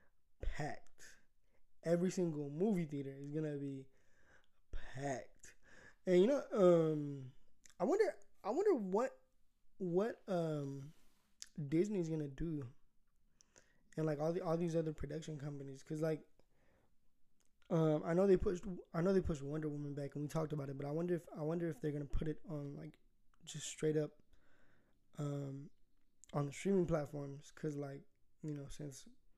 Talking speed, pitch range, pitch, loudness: 155 wpm, 145-175 Hz, 155 Hz, -39 LUFS